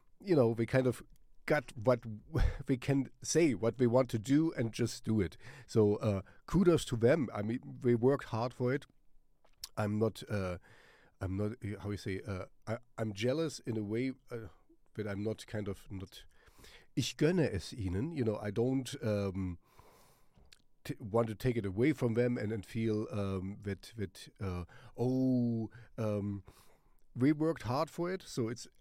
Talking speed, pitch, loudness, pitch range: 180 wpm, 115 Hz, -35 LUFS, 105-130 Hz